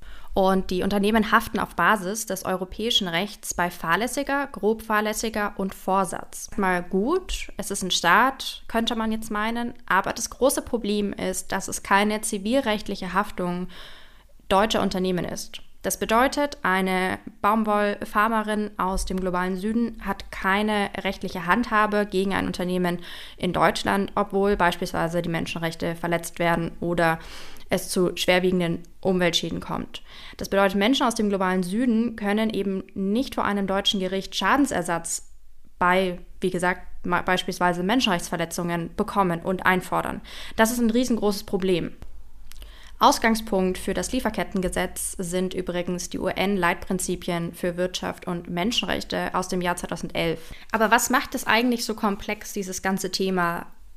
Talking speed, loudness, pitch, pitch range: 135 wpm, -24 LUFS, 195 Hz, 180-215 Hz